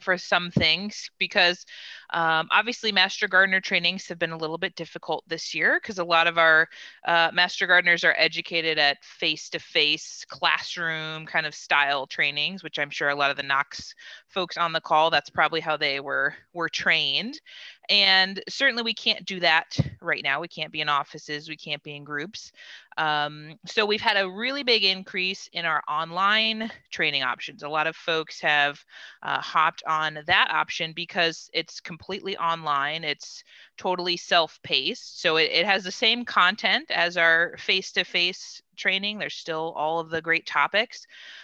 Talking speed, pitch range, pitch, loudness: 175 wpm, 155-190 Hz, 170 Hz, -23 LUFS